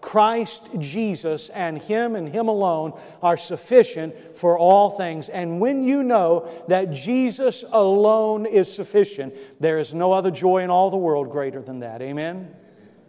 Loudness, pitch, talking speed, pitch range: -21 LUFS, 185 Hz, 155 wpm, 160-215 Hz